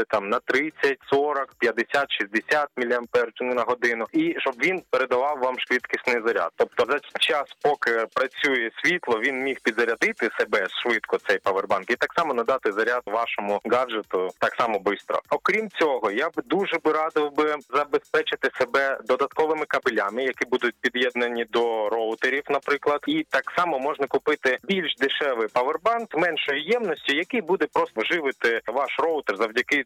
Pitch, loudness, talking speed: 150 Hz, -24 LUFS, 150 wpm